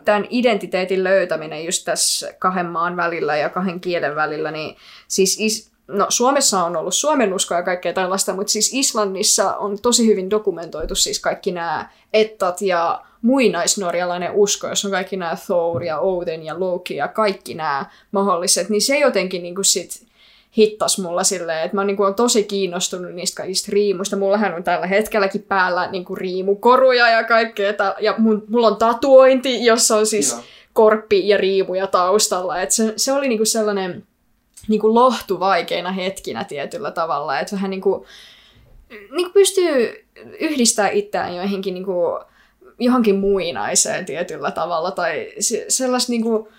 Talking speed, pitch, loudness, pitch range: 140 wpm, 200 Hz, -18 LUFS, 185-225 Hz